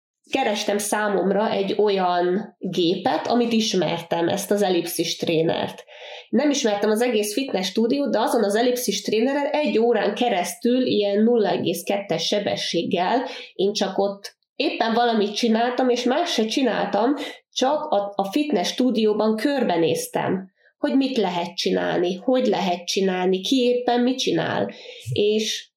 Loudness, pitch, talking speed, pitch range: -22 LUFS, 215 Hz, 130 wpm, 195-245 Hz